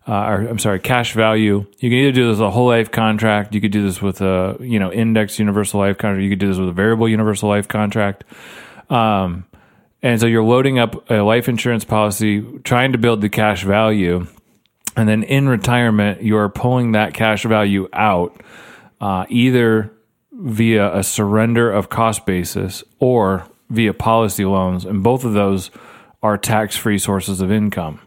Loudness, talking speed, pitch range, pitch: -16 LUFS, 180 wpm, 100-115 Hz, 105 Hz